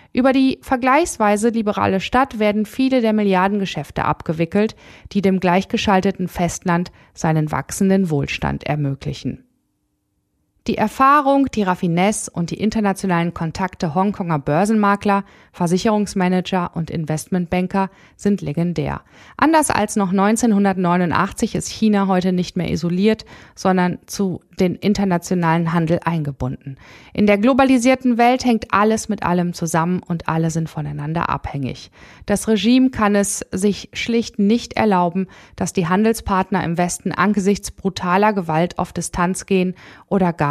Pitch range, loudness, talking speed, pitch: 170-210 Hz, -18 LUFS, 125 wpm, 190 Hz